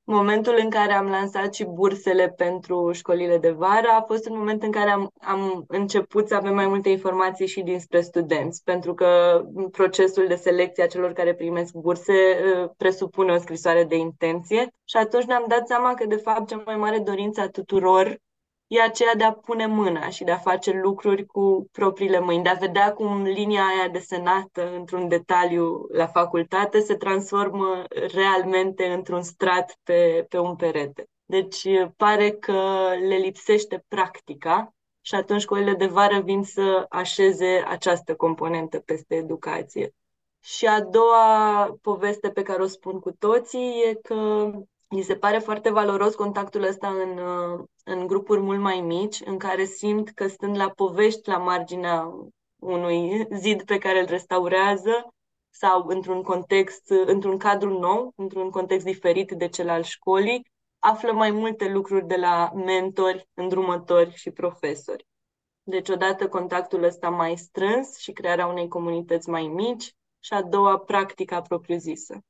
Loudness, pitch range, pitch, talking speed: -23 LUFS, 180-205 Hz, 190 Hz, 155 wpm